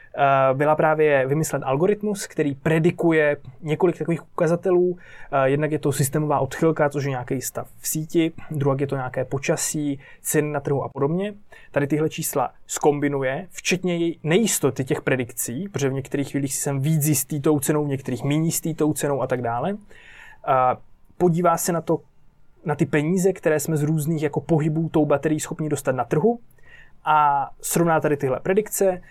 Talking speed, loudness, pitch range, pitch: 165 wpm, -22 LUFS, 140-165 Hz, 155 Hz